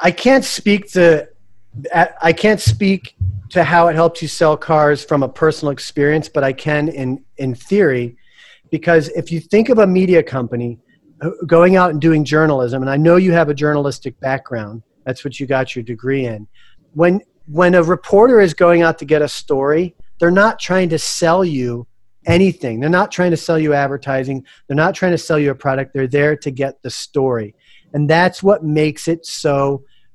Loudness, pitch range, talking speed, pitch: -15 LUFS, 135-170 Hz, 195 wpm, 150 Hz